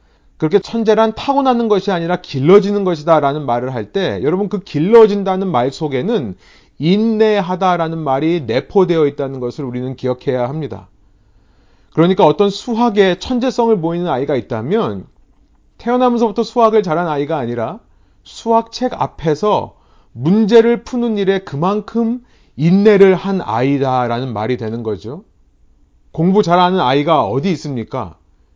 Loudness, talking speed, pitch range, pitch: -15 LUFS, 320 characters per minute, 125-210 Hz, 170 Hz